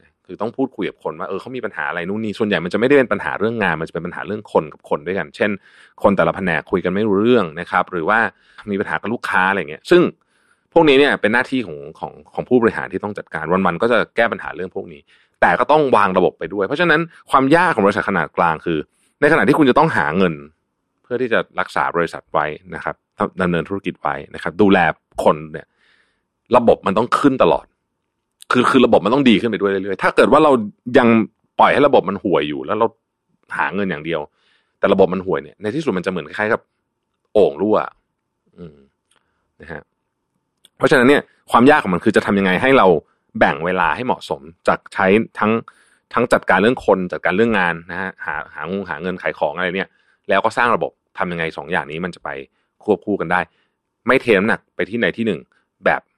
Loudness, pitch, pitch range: -17 LUFS, 90 Hz, 80-105 Hz